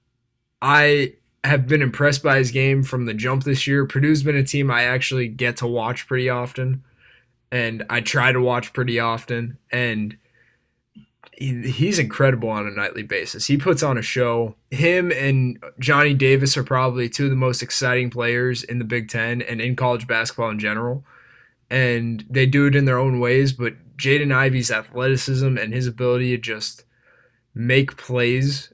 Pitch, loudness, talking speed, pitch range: 125 Hz, -20 LUFS, 175 wpm, 120-135 Hz